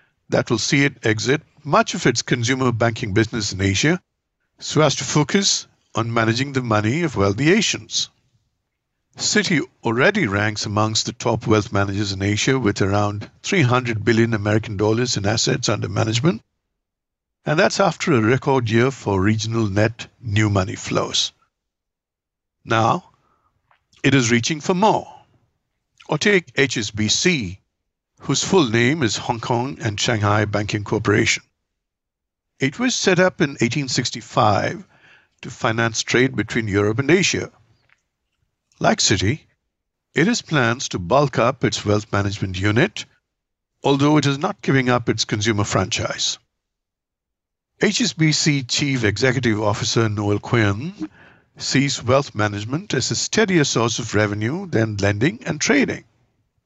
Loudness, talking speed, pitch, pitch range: -19 LUFS, 135 wpm, 120 Hz, 105-140 Hz